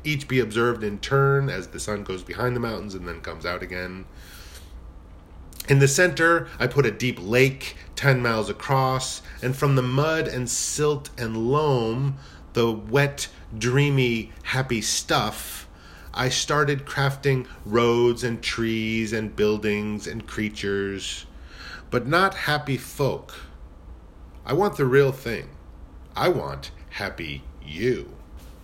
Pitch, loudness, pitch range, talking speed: 115 Hz, -24 LUFS, 85-135 Hz, 135 wpm